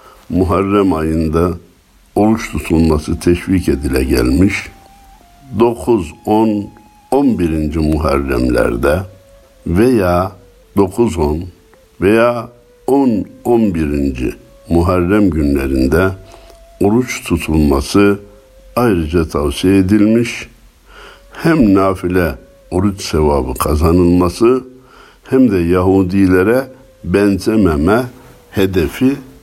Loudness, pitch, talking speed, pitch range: -14 LUFS, 95 Hz, 70 wpm, 85-110 Hz